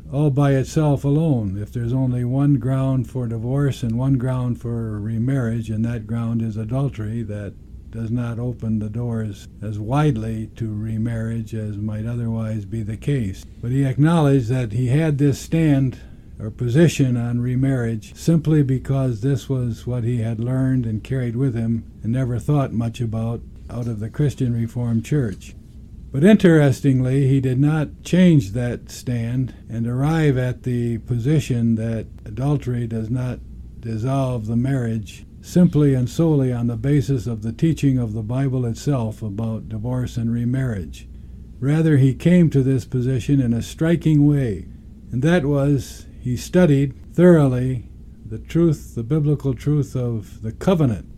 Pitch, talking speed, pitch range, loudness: 125 Hz, 155 wpm, 115-140 Hz, -20 LUFS